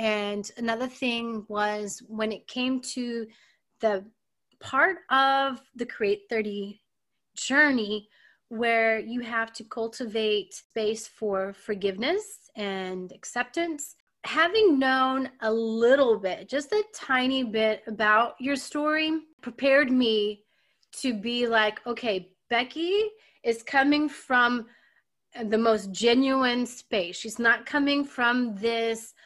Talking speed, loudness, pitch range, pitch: 115 wpm, -26 LUFS, 215-265 Hz, 235 Hz